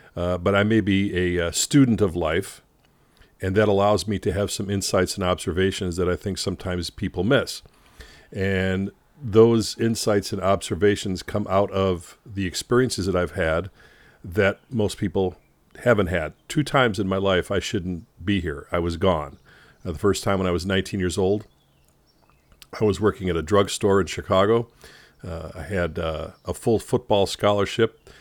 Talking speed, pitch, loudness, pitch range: 175 wpm, 95 Hz, -23 LUFS, 90-105 Hz